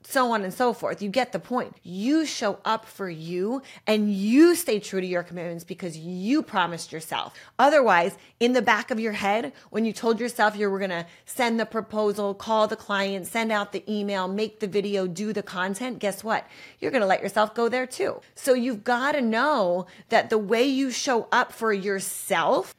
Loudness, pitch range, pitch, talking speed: -25 LUFS, 195-240 Hz, 215 Hz, 210 wpm